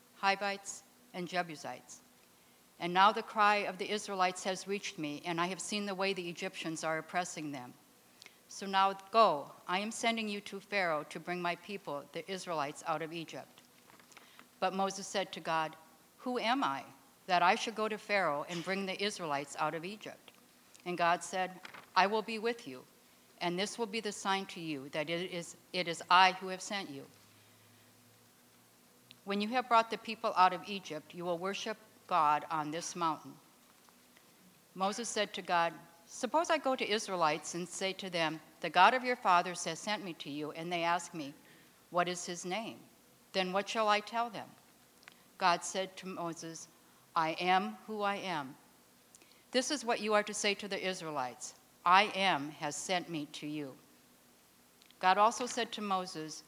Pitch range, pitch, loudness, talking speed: 160-205 Hz, 185 Hz, -34 LUFS, 185 wpm